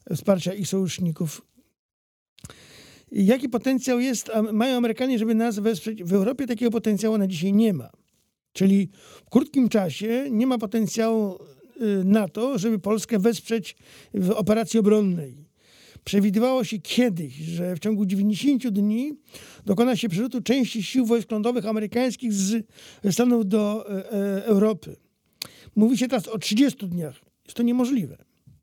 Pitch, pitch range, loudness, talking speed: 220 Hz, 200-240 Hz, -23 LUFS, 135 wpm